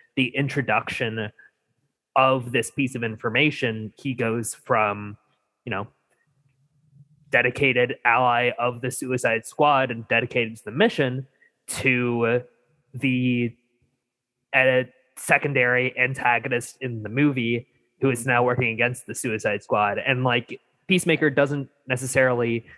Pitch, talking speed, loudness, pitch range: 125 Hz, 115 wpm, -23 LUFS, 120-135 Hz